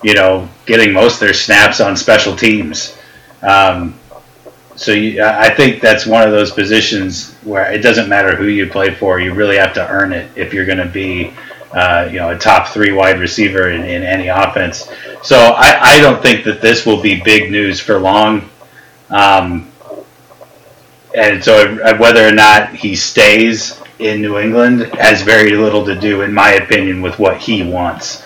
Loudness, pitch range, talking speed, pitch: -9 LUFS, 95-110 Hz, 185 wpm, 105 Hz